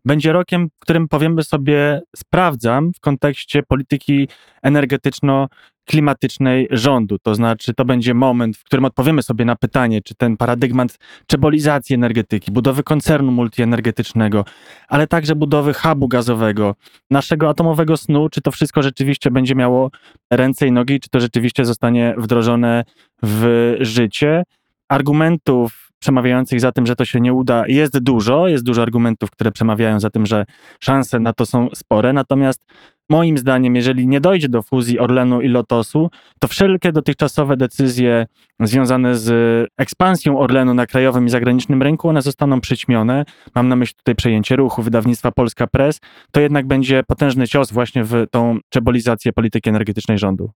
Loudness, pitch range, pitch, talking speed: -16 LUFS, 120-145 Hz, 130 Hz, 150 wpm